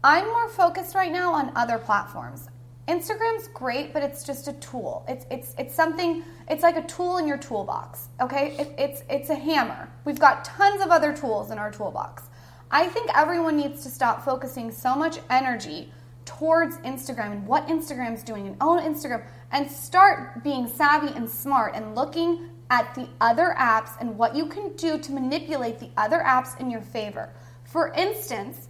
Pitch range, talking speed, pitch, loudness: 230-330 Hz, 180 wpm, 280 Hz, -25 LUFS